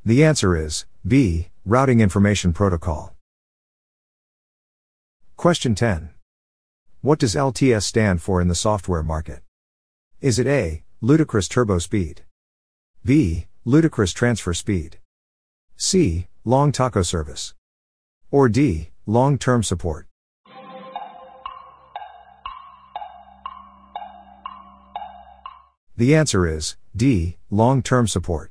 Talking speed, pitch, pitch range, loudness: 95 wpm, 105 Hz, 85-140 Hz, -20 LUFS